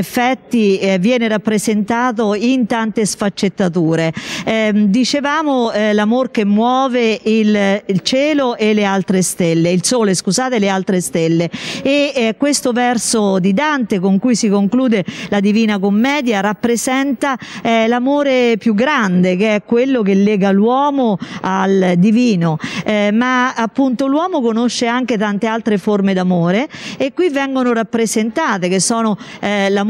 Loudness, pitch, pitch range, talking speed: -15 LUFS, 220 Hz, 200-250 Hz, 140 wpm